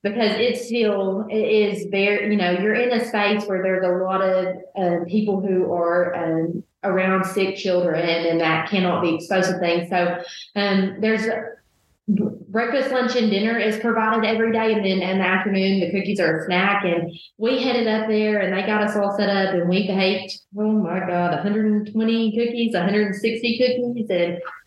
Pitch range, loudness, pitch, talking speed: 185-220 Hz, -21 LUFS, 200 Hz, 190 wpm